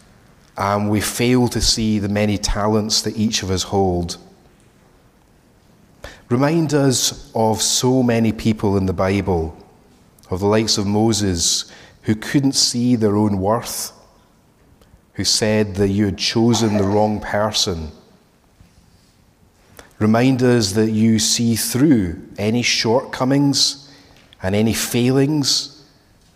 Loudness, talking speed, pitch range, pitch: -17 LUFS, 120 wpm, 100-120 Hz, 110 Hz